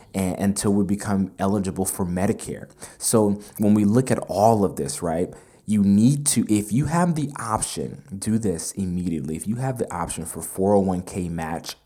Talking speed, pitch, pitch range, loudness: 170 wpm, 100 Hz, 95-110 Hz, -23 LUFS